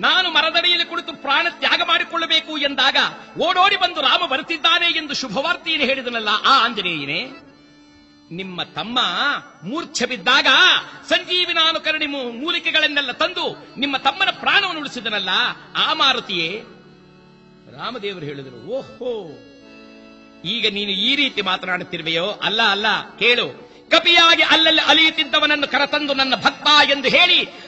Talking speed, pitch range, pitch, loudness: 100 wpm, 210-335 Hz, 280 Hz, -16 LUFS